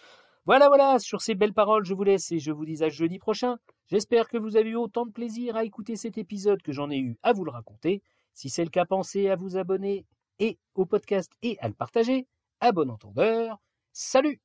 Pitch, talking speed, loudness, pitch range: 210 Hz, 230 wpm, -26 LUFS, 180-230 Hz